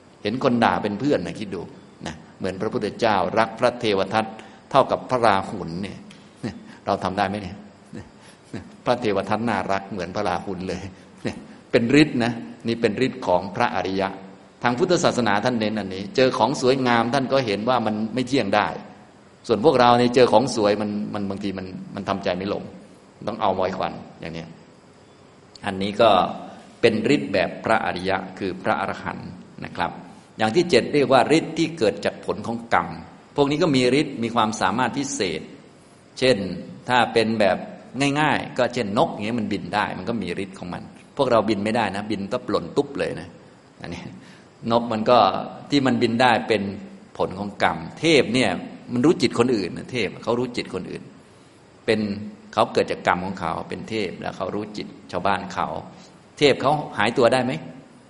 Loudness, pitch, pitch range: -22 LUFS, 110 Hz, 100-125 Hz